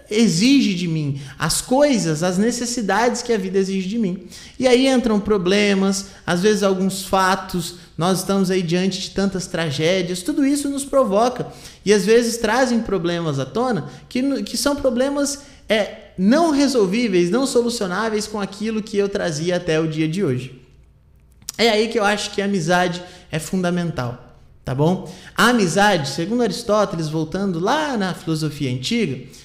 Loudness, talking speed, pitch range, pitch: -19 LUFS, 160 wpm, 175-230 Hz, 195 Hz